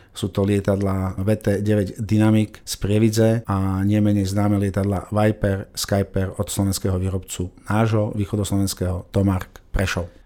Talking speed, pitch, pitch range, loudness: 115 wpm, 100 Hz, 95-105 Hz, -21 LUFS